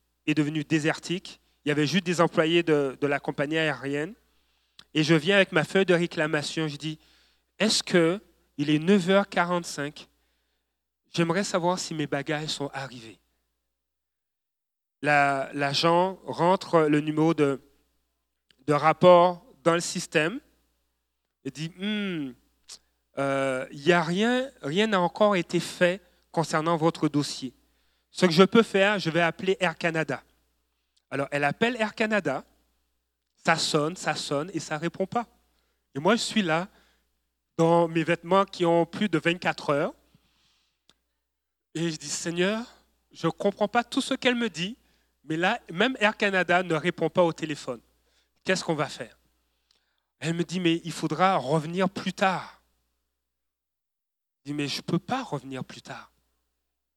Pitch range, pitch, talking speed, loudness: 110-180 Hz, 155 Hz, 155 wpm, -26 LUFS